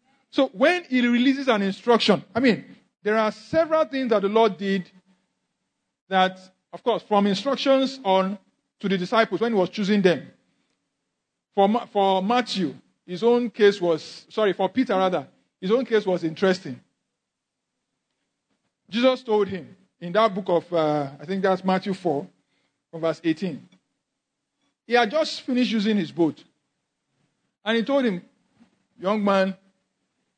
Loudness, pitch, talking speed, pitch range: -23 LUFS, 200 Hz, 150 wpm, 185-235 Hz